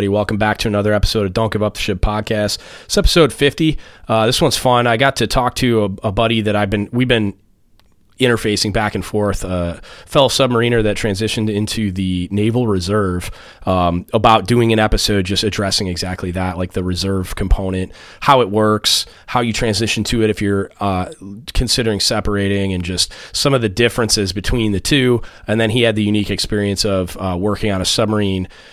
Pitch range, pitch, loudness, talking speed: 95-115 Hz, 105 Hz, -16 LUFS, 195 wpm